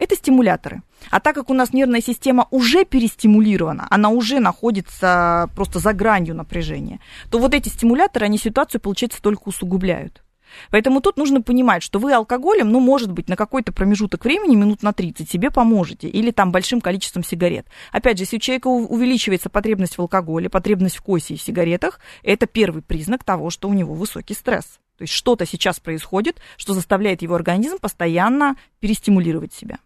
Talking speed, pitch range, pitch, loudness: 175 wpm, 185-245 Hz, 210 Hz, -18 LUFS